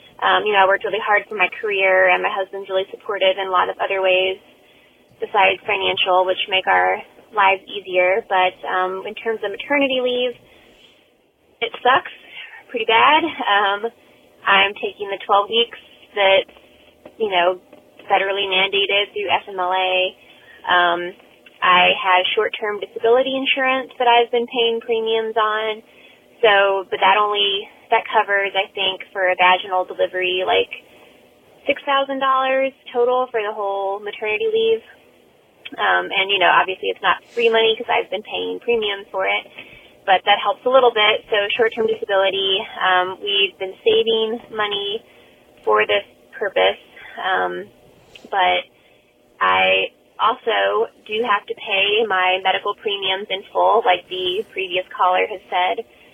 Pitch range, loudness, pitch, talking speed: 190-230 Hz, -18 LUFS, 205 Hz, 145 wpm